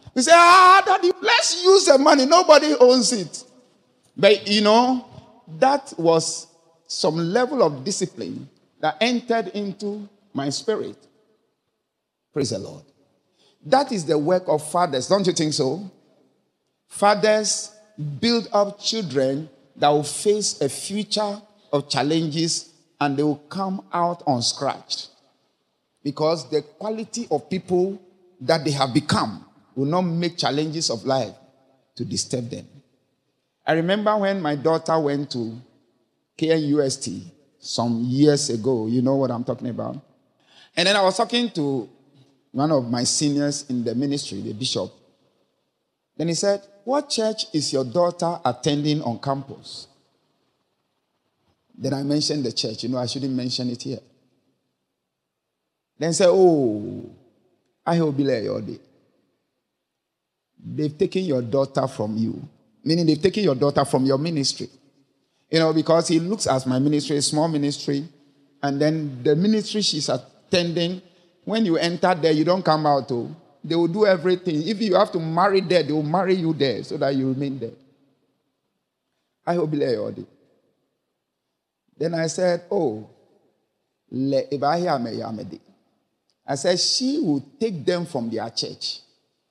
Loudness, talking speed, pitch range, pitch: -21 LUFS, 150 wpm, 140-195 Hz, 160 Hz